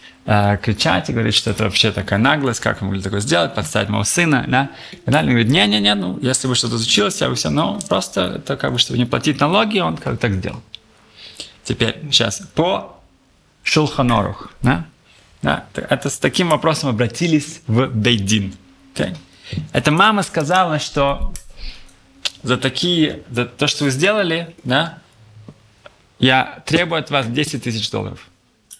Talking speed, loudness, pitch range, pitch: 165 wpm, -17 LUFS, 110-150 Hz, 125 Hz